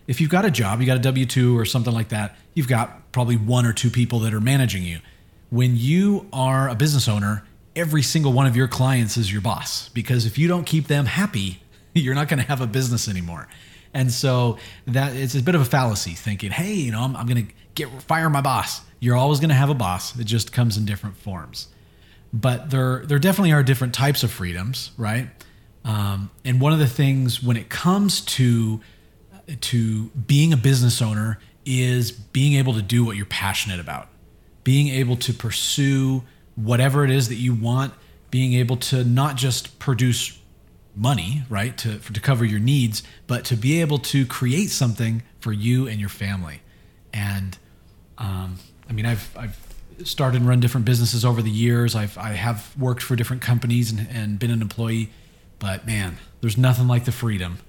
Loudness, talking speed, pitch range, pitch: -21 LUFS, 200 wpm, 105-130 Hz, 120 Hz